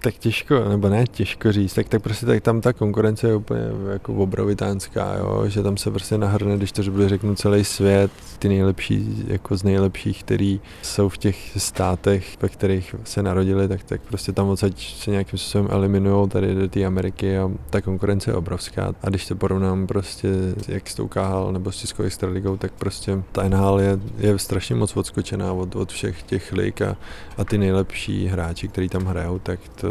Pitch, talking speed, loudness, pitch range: 100 Hz, 195 wpm, -22 LUFS, 95-105 Hz